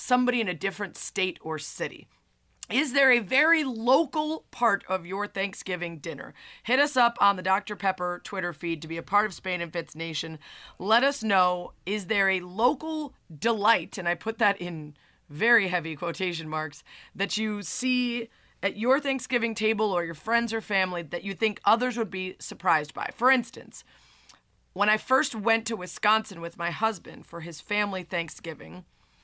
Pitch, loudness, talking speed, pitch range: 200 Hz, -27 LUFS, 180 wpm, 175-235 Hz